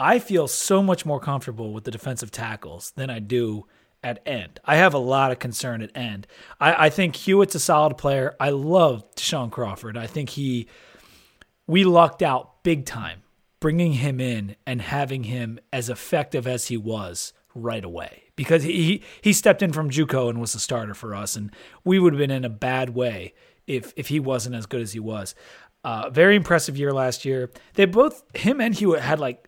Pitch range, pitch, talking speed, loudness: 120-160 Hz, 135 Hz, 200 wpm, -22 LUFS